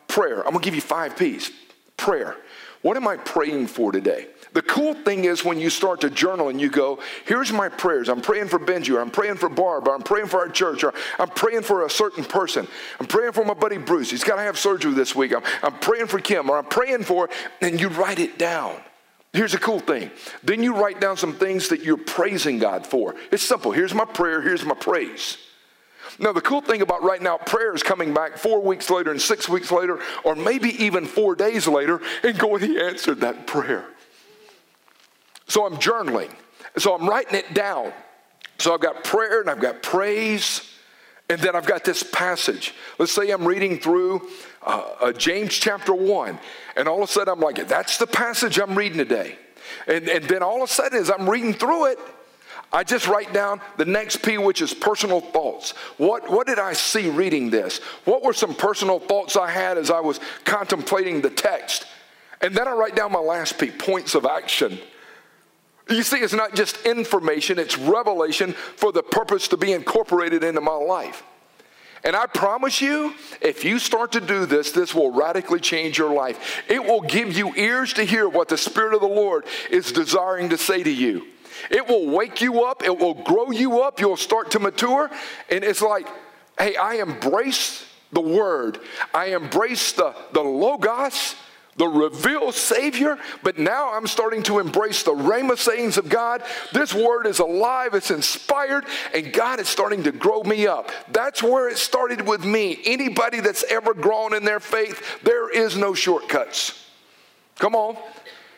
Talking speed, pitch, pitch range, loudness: 195 wpm, 215 Hz, 185-255 Hz, -21 LUFS